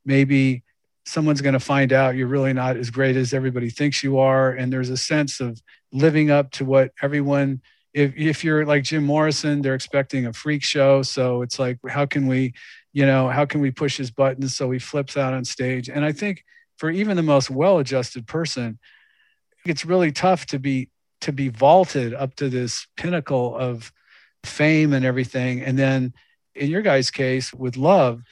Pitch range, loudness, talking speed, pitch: 130-150 Hz, -21 LUFS, 190 wpm, 135 Hz